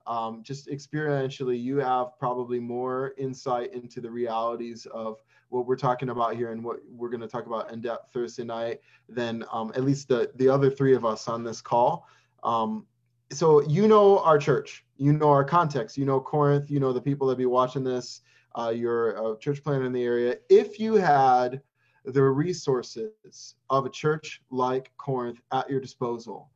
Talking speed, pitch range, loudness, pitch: 185 wpm, 120-140 Hz, -26 LUFS, 130 Hz